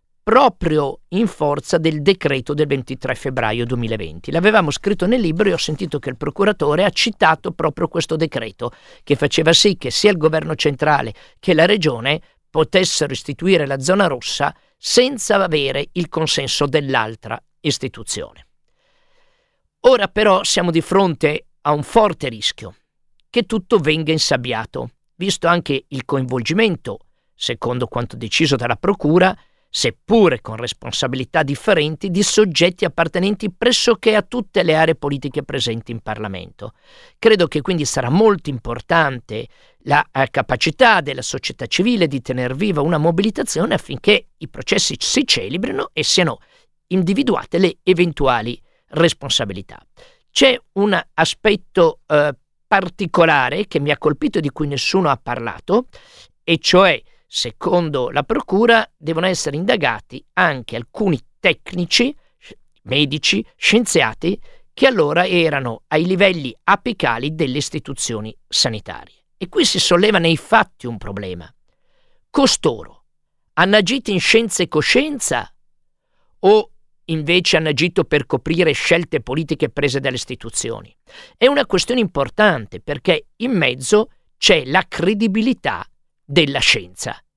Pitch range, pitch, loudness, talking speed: 140-205 Hz, 165 Hz, -17 LUFS, 130 wpm